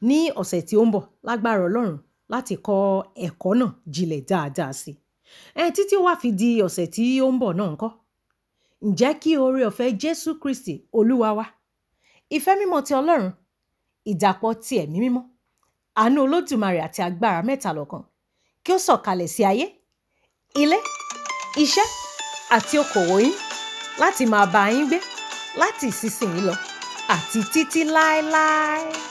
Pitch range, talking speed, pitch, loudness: 200-310 Hz, 145 wpm, 240 Hz, -22 LUFS